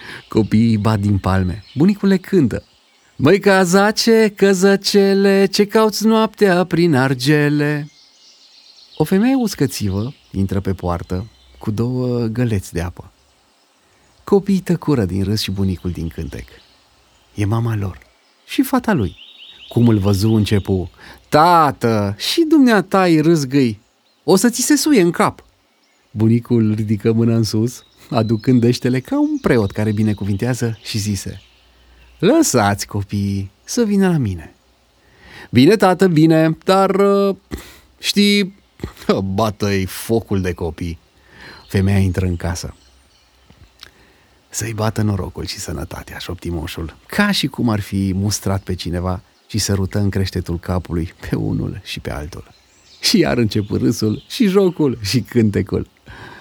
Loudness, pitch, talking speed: -17 LUFS, 110 Hz, 130 wpm